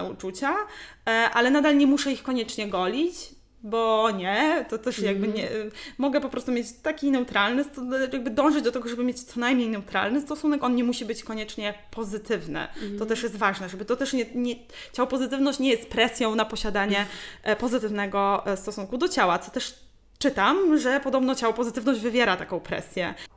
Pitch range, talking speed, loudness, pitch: 215-270 Hz, 170 wpm, -25 LUFS, 240 Hz